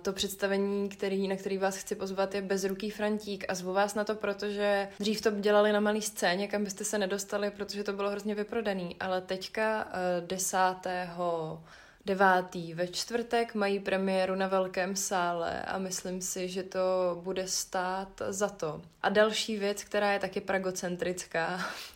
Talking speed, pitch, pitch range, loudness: 160 wpm, 195 Hz, 185-205 Hz, -31 LUFS